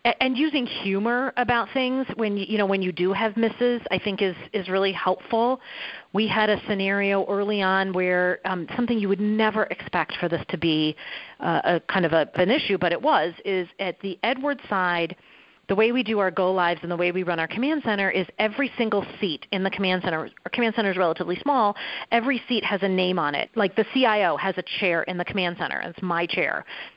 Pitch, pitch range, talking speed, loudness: 195 Hz, 180-225 Hz, 220 wpm, -24 LUFS